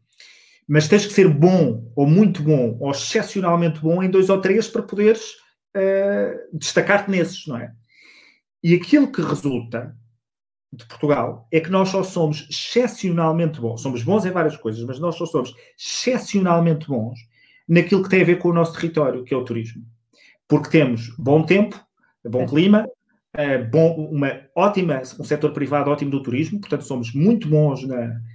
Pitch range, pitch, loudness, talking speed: 135-190 Hz, 160 Hz, -19 LUFS, 170 wpm